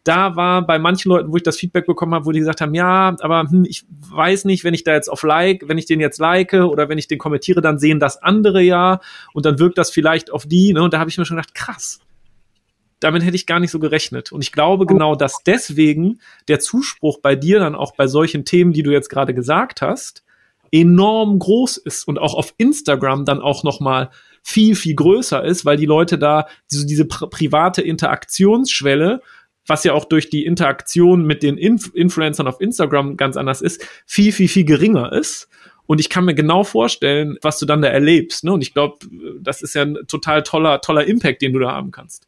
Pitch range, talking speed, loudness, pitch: 150-180 Hz, 225 wpm, -15 LUFS, 160 Hz